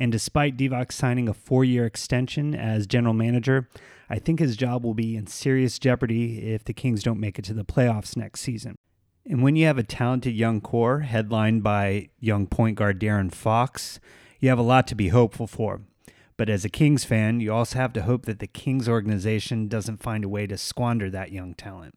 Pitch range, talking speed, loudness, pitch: 110-125 Hz, 210 wpm, -24 LUFS, 115 Hz